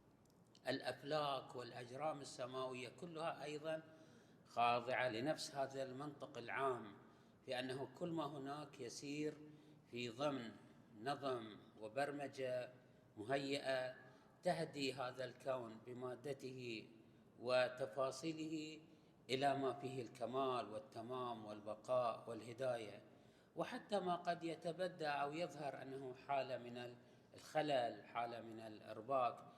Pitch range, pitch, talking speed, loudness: 125-150 Hz, 130 Hz, 95 wpm, -46 LUFS